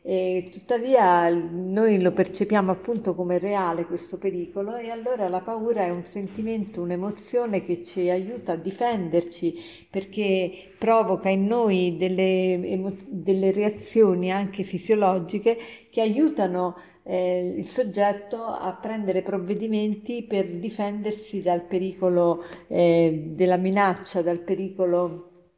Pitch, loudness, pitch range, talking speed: 190 Hz, -25 LUFS, 180-210 Hz, 115 wpm